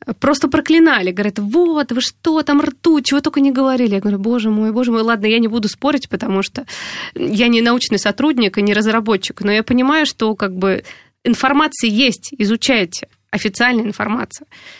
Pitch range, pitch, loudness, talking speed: 215-285 Hz, 235 Hz, -15 LUFS, 175 wpm